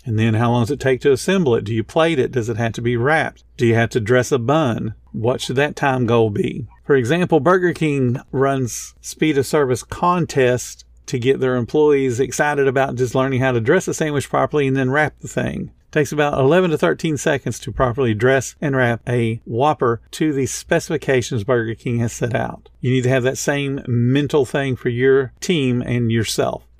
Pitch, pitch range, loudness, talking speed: 130 Hz, 120-145 Hz, -18 LUFS, 215 wpm